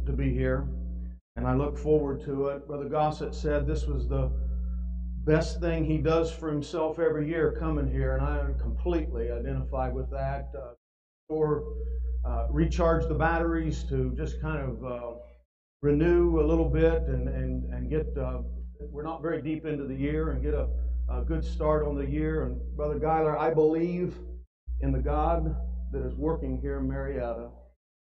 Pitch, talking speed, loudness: 75 Hz, 175 wpm, -29 LUFS